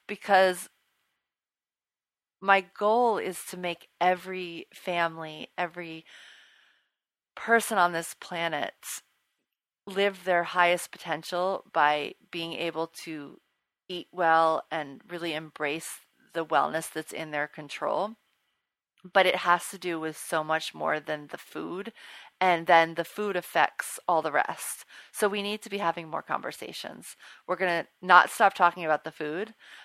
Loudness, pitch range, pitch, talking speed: -28 LUFS, 160-185 Hz, 175 Hz, 140 wpm